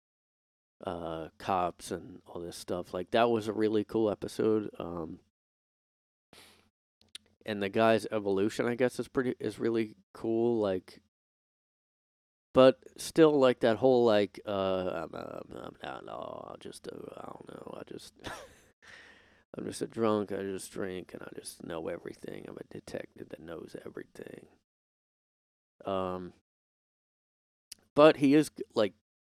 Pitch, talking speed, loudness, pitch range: 110 Hz, 140 wpm, -30 LUFS, 95-120 Hz